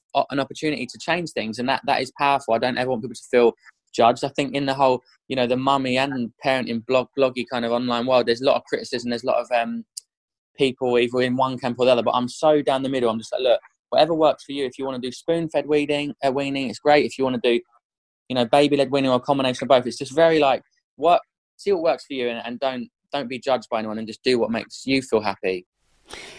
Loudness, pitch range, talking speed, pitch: -22 LUFS, 120-140 Hz, 270 wpm, 130 Hz